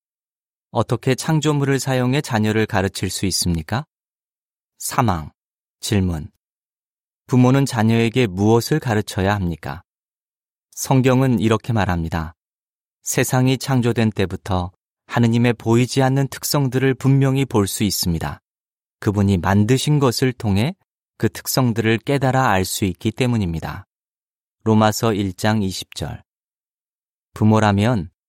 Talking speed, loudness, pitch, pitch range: 250 characters per minute, -19 LUFS, 110 Hz, 95-130 Hz